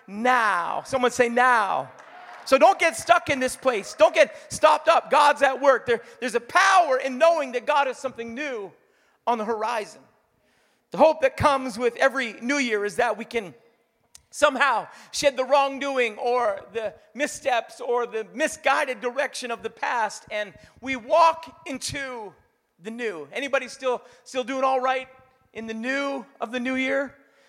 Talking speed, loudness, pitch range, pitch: 170 wpm, -23 LUFS, 240-285 Hz, 260 Hz